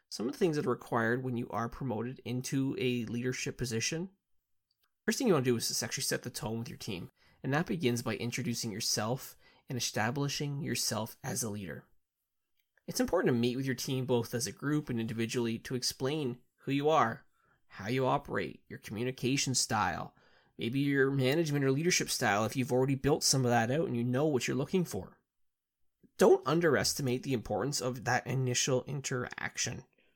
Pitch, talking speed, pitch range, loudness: 125 Hz, 190 wpm, 120-140 Hz, -32 LUFS